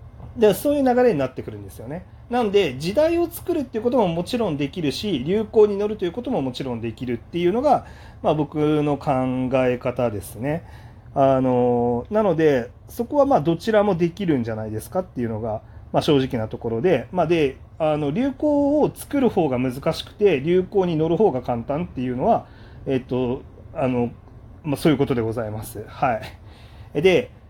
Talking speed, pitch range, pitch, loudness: 365 characters per minute, 120-200 Hz, 140 Hz, -22 LUFS